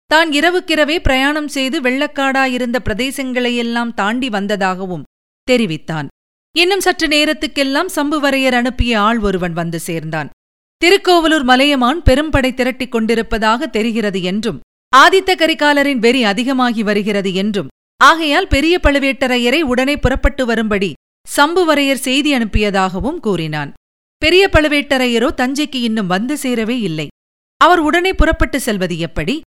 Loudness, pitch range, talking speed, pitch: -14 LUFS, 215-300 Hz, 105 wpm, 255 Hz